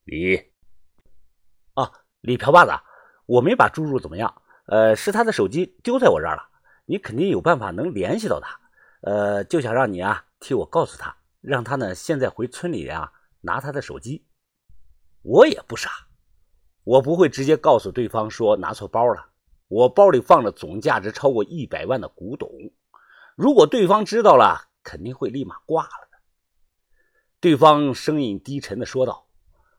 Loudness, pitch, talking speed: -20 LUFS, 130 Hz, 245 characters per minute